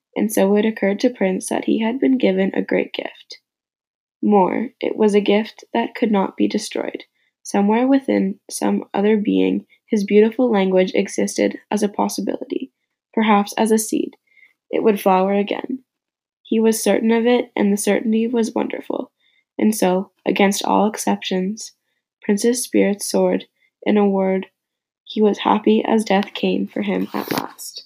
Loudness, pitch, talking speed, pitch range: -19 LUFS, 210 Hz, 160 wpm, 190-230 Hz